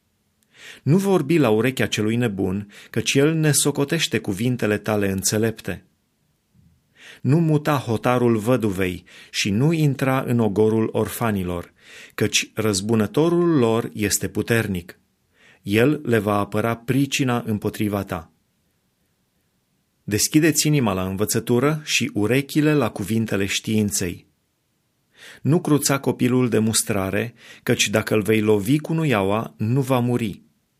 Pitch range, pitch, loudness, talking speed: 105-135 Hz, 115 Hz, -21 LUFS, 115 wpm